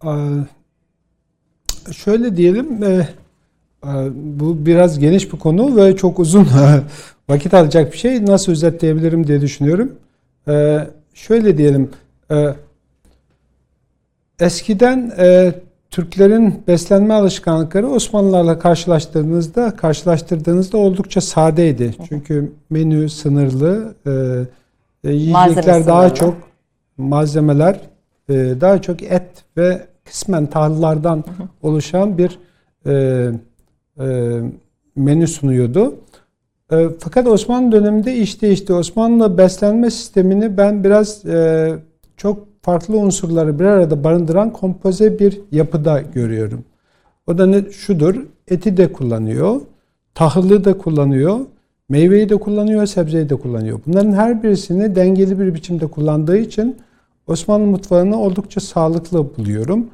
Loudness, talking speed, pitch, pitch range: -14 LUFS, 100 wpm, 175 Hz, 150-195 Hz